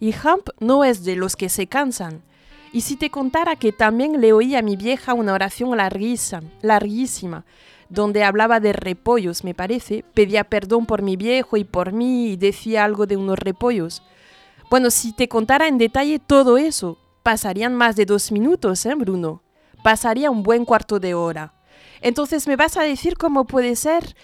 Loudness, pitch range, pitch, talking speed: -19 LUFS, 200-255 Hz, 225 Hz, 180 wpm